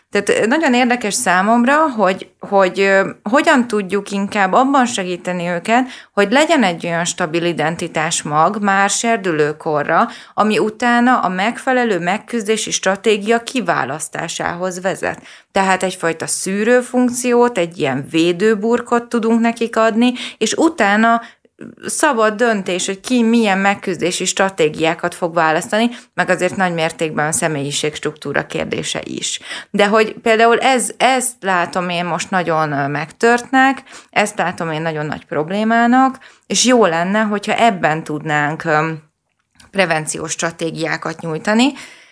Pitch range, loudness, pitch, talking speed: 170-235 Hz, -16 LUFS, 200 Hz, 120 wpm